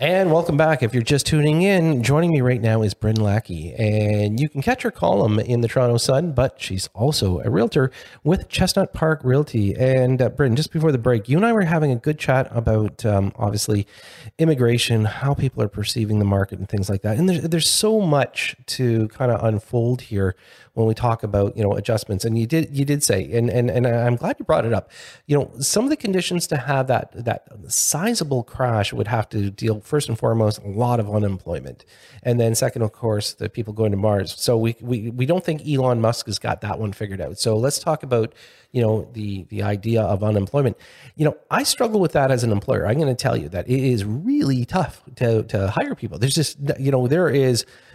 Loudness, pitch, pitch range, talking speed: -20 LUFS, 120 Hz, 110-145 Hz, 230 wpm